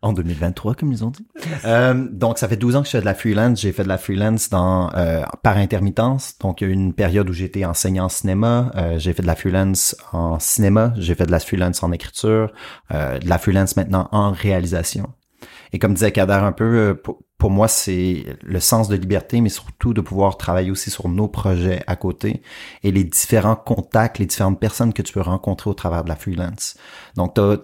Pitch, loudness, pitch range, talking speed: 100 Hz, -19 LUFS, 90-110 Hz, 225 wpm